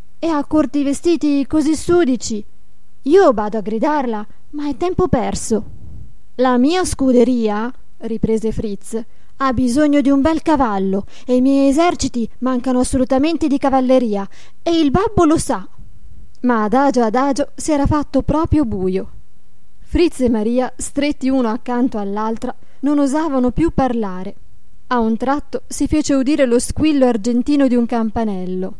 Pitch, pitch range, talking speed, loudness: 260 Hz, 225-290 Hz, 145 wpm, -17 LUFS